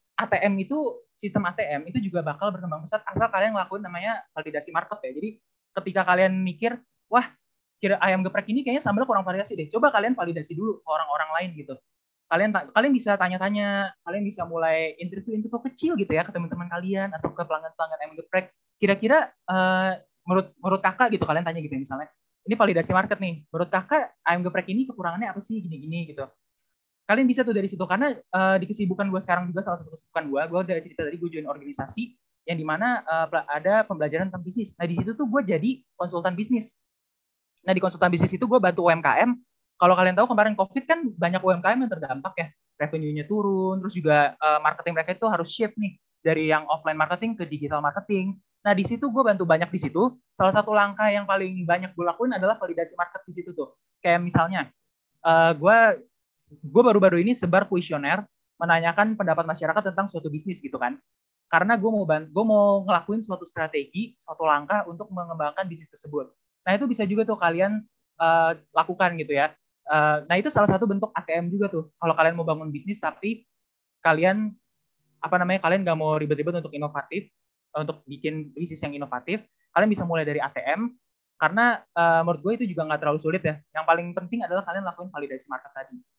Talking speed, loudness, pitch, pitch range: 190 wpm, -24 LUFS, 185 Hz, 160-210 Hz